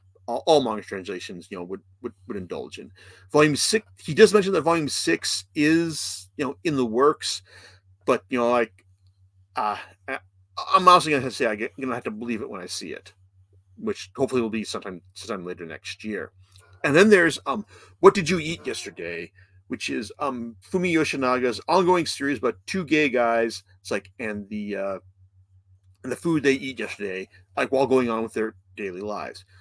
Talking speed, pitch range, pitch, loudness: 195 wpm, 95-140 Hz, 105 Hz, -24 LUFS